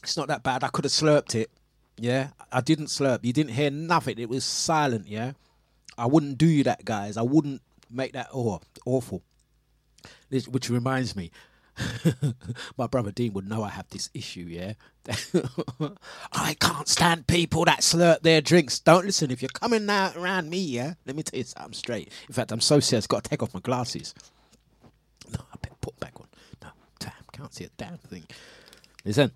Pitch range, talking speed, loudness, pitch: 120-155 Hz, 190 wpm, -25 LUFS, 135 Hz